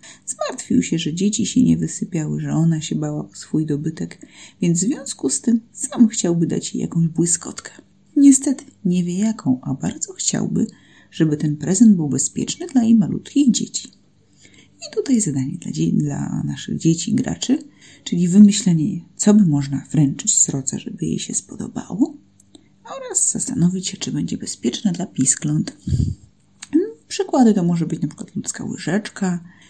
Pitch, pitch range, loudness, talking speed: 195 Hz, 160-235 Hz, -19 LUFS, 160 wpm